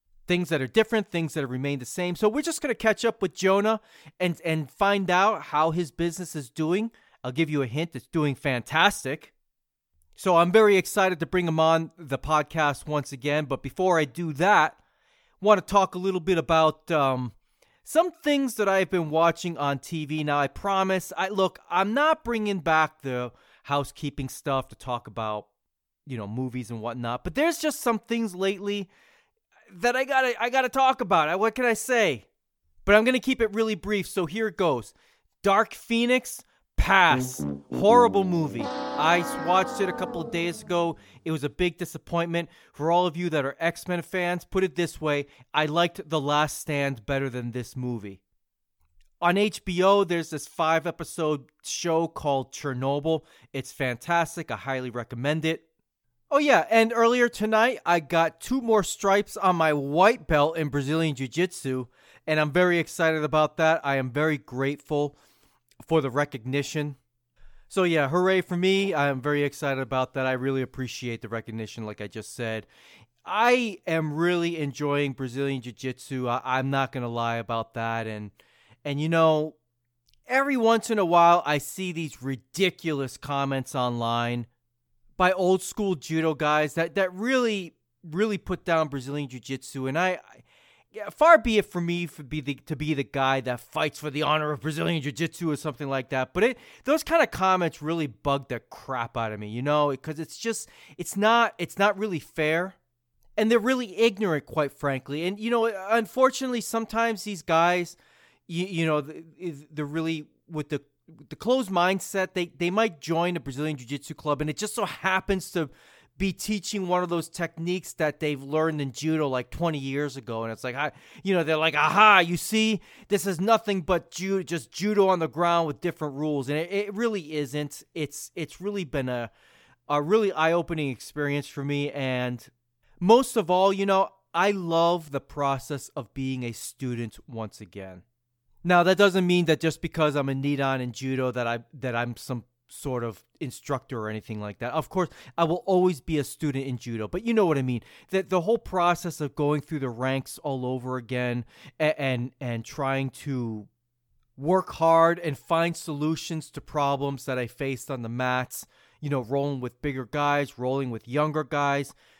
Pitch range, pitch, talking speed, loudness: 135-185 Hz, 155 Hz, 185 wpm, -26 LUFS